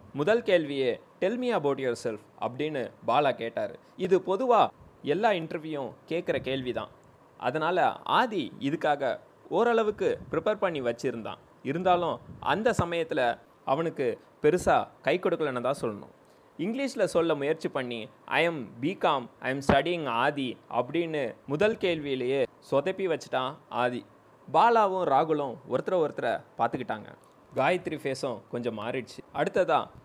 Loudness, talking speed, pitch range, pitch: -28 LUFS, 115 wpm, 130-190 Hz, 160 Hz